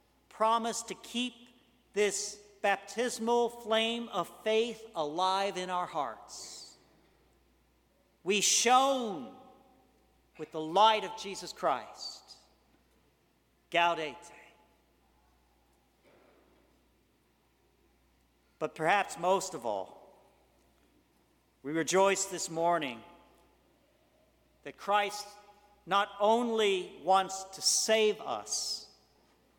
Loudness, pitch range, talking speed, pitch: -31 LUFS, 165-225 Hz, 75 wpm, 195 Hz